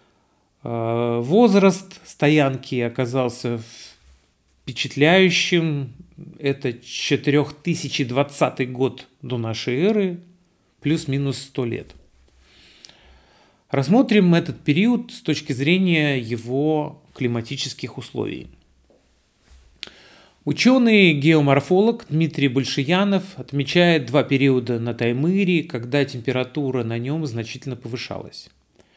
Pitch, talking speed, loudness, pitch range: 140 Hz, 75 wpm, -20 LUFS, 120-165 Hz